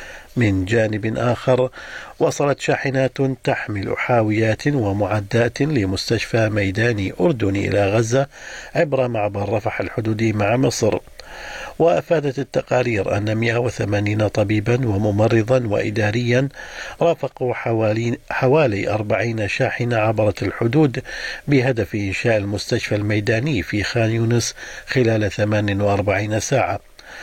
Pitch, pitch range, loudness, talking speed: 115 Hz, 105-130 Hz, -20 LUFS, 95 wpm